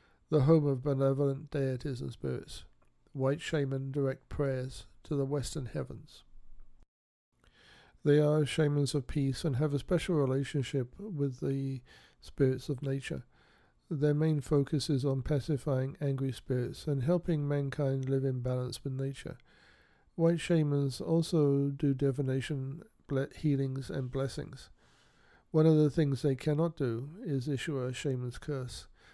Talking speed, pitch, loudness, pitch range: 135 wpm, 140 Hz, -32 LUFS, 135-150 Hz